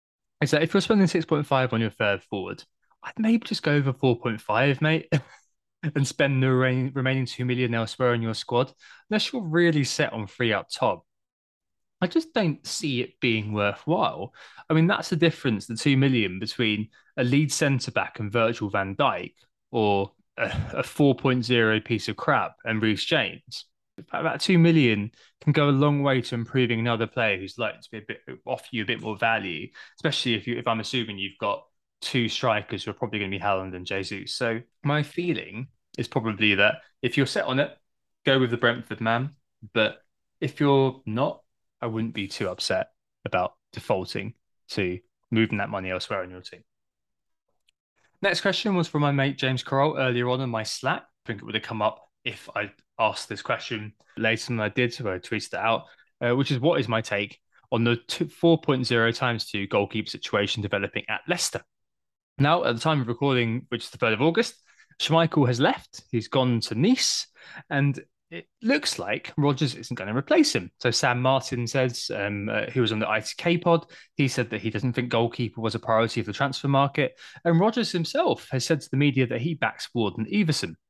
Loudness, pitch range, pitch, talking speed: -25 LUFS, 110-145 Hz, 125 Hz, 195 wpm